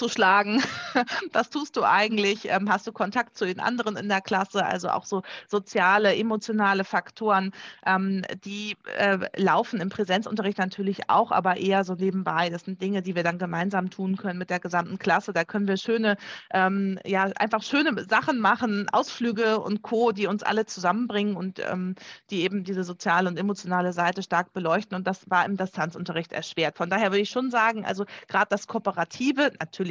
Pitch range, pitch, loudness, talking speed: 185-215 Hz, 195 Hz, -25 LUFS, 175 wpm